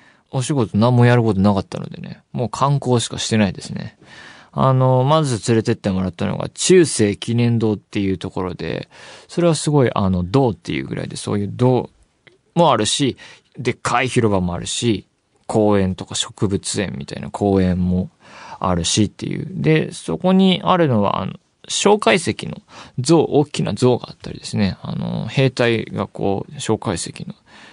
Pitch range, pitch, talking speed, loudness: 100-135 Hz, 115 Hz, 330 characters per minute, -18 LUFS